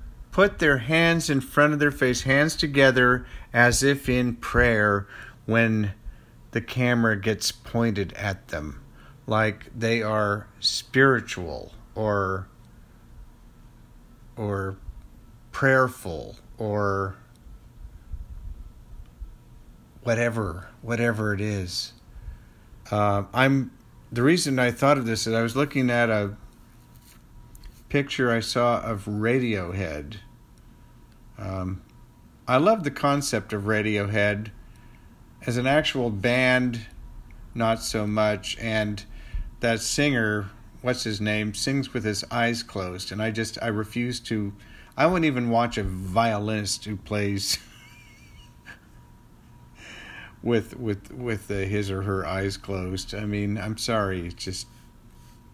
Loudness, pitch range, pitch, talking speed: -24 LUFS, 100-120 Hz, 110 Hz, 115 wpm